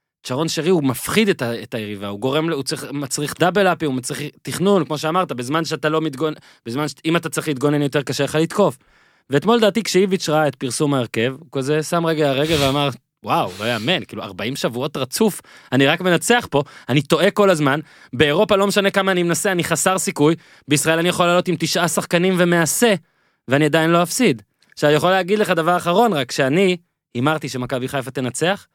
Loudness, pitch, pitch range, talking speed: -19 LUFS, 155 Hz, 140-180 Hz, 185 wpm